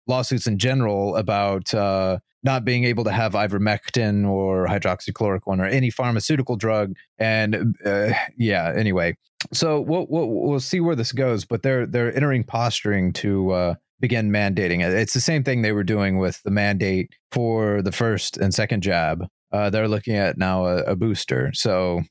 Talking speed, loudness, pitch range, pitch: 175 wpm, -22 LUFS, 100-120 Hz, 110 Hz